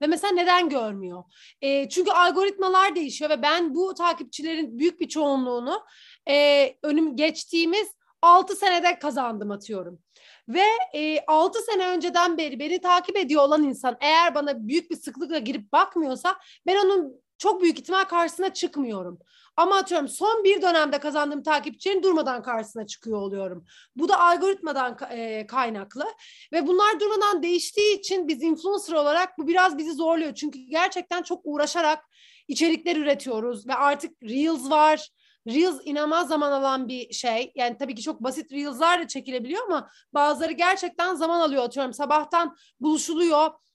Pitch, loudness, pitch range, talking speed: 315 Hz, -23 LUFS, 275-355 Hz, 145 wpm